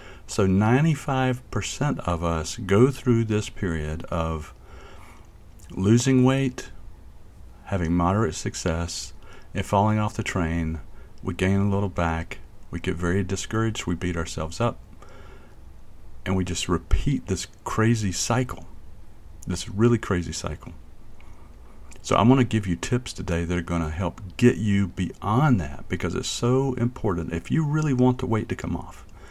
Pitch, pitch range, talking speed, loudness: 95 Hz, 85-115 Hz, 150 wpm, -25 LUFS